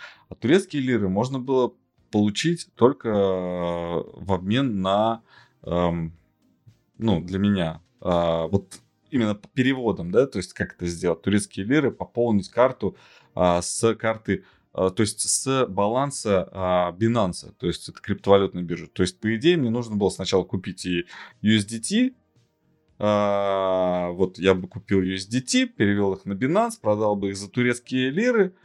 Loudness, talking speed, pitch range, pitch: -24 LUFS, 150 wpm, 95-120 Hz, 100 Hz